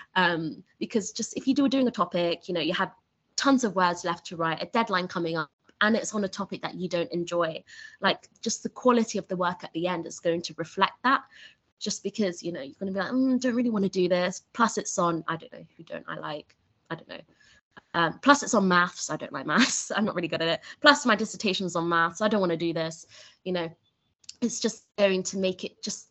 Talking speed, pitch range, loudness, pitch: 260 wpm, 170-225 Hz, -27 LUFS, 190 Hz